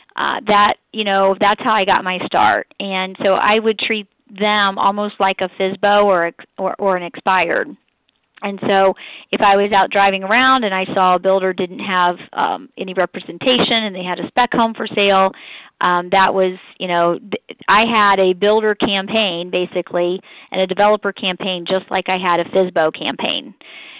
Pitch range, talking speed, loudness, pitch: 185-210 Hz, 185 wpm, -16 LUFS, 195 Hz